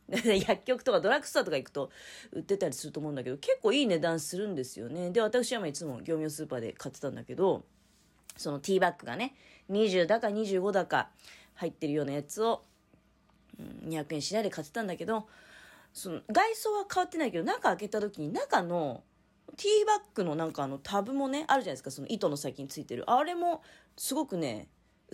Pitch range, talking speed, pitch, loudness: 155-250 Hz, 395 characters per minute, 195 Hz, -32 LUFS